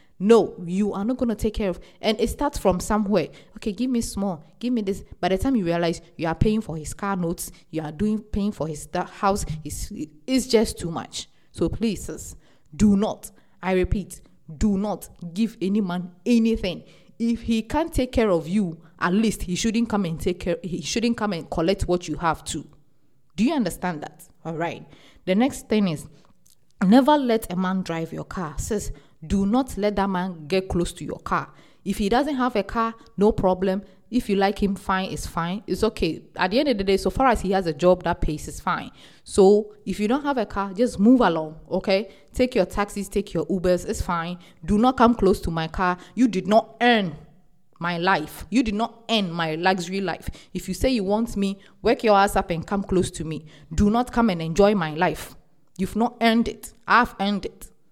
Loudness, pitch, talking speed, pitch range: -23 LUFS, 195 Hz, 220 wpm, 175-220 Hz